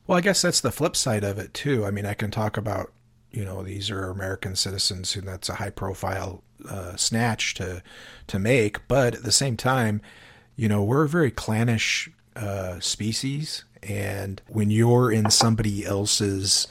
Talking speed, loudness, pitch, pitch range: 185 wpm, -24 LUFS, 105 Hz, 100-120 Hz